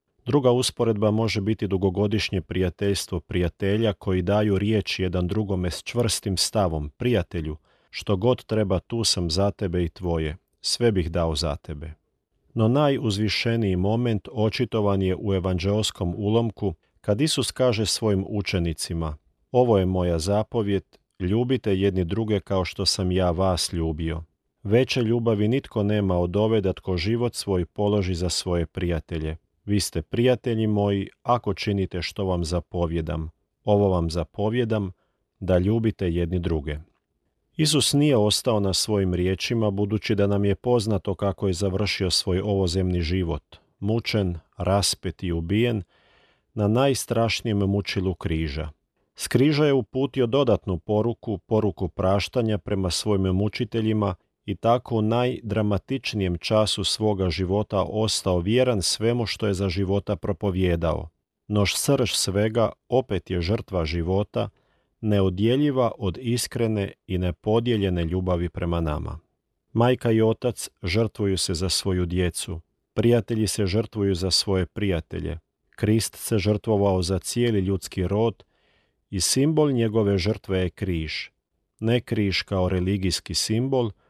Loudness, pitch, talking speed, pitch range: -24 LUFS, 100 Hz, 130 wpm, 90-110 Hz